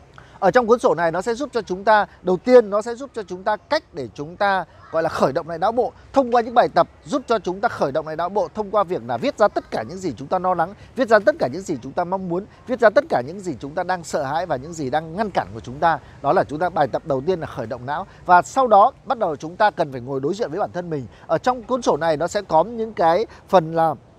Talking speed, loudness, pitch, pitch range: 320 wpm, -21 LUFS, 185 Hz, 160-225 Hz